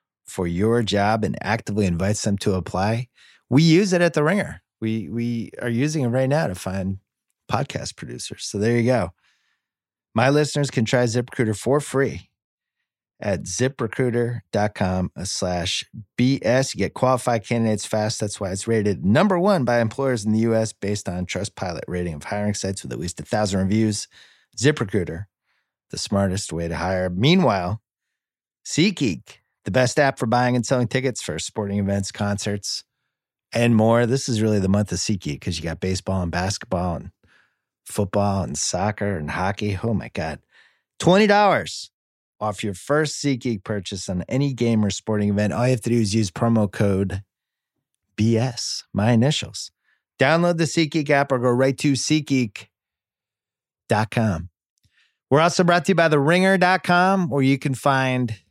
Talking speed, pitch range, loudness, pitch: 165 wpm, 100-130 Hz, -22 LUFS, 110 Hz